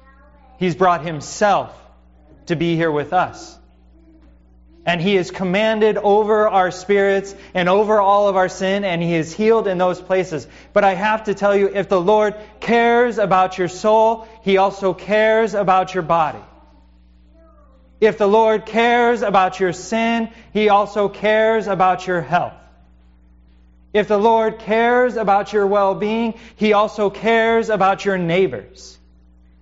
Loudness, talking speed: -17 LUFS, 150 wpm